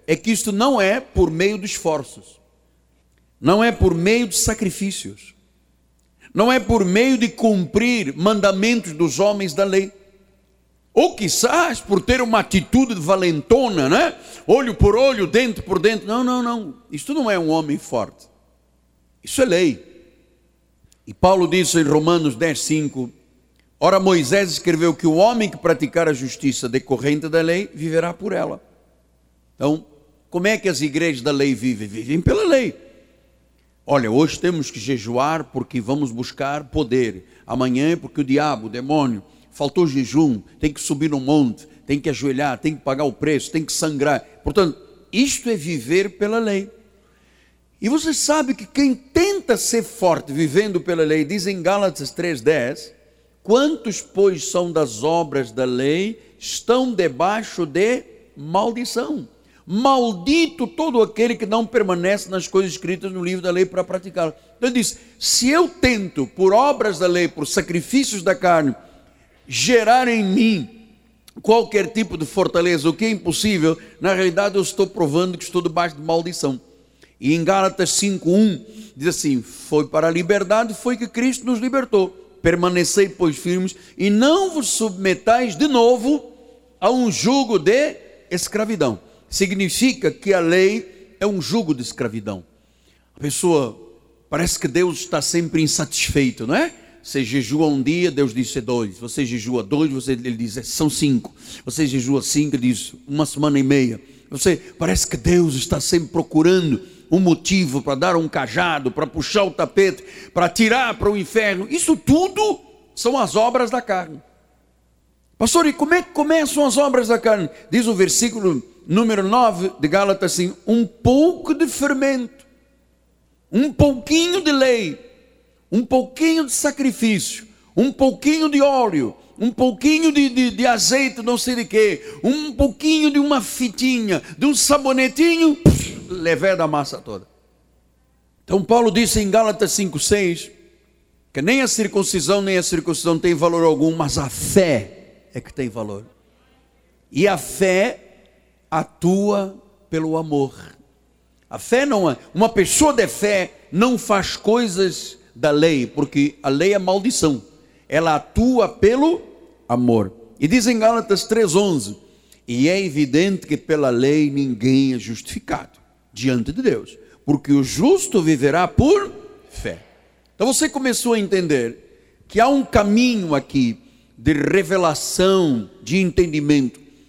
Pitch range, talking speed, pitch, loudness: 150-230 Hz, 155 wpm, 185 Hz, -19 LUFS